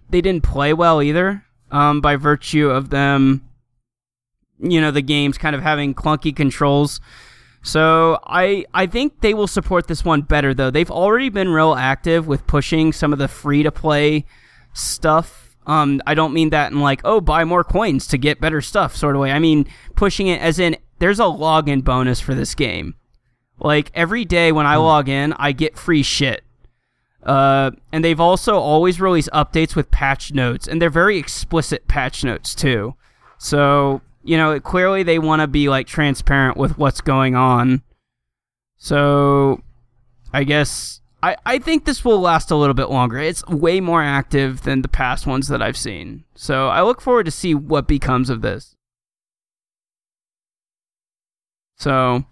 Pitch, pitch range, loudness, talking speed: 150 Hz, 135-165 Hz, -17 LUFS, 170 wpm